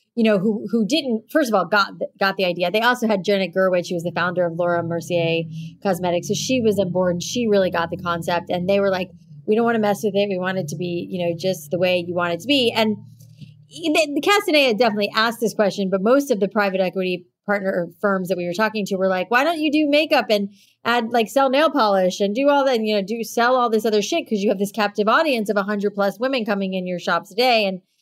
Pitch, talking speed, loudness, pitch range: 205 Hz, 270 wpm, -20 LUFS, 180-230 Hz